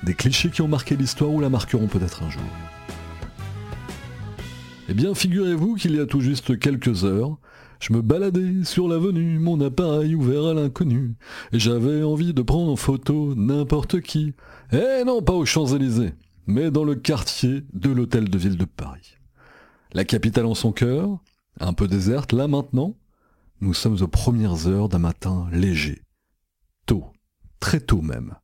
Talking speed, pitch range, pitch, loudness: 165 wpm, 95-150 Hz, 125 Hz, -22 LUFS